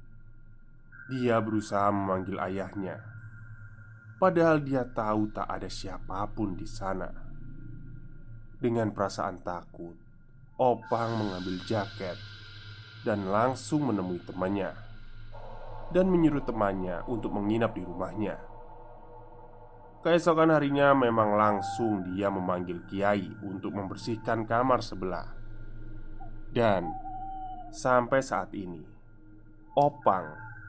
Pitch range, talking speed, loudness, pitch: 100-125 Hz, 90 wpm, -29 LUFS, 110 Hz